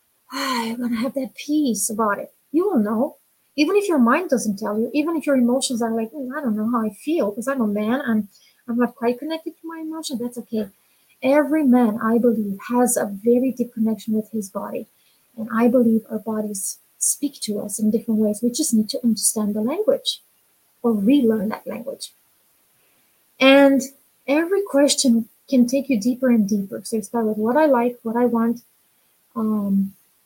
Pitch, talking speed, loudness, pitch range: 240 Hz, 195 wpm, -21 LUFS, 220-275 Hz